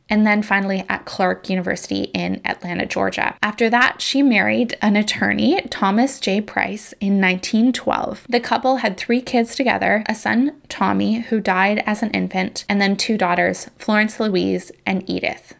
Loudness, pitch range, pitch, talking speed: -19 LUFS, 195-240 Hz, 215 Hz, 160 wpm